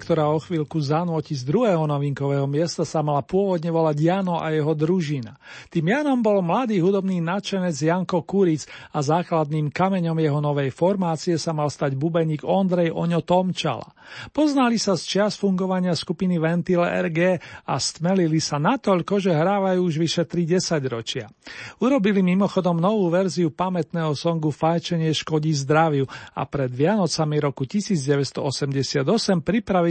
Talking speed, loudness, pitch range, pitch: 140 wpm, -22 LUFS, 155-185 Hz, 170 Hz